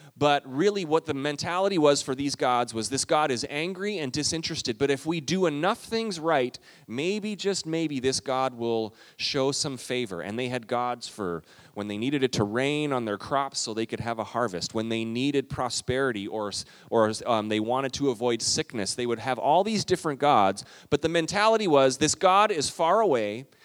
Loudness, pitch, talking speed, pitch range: -26 LUFS, 135 Hz, 205 wpm, 120-155 Hz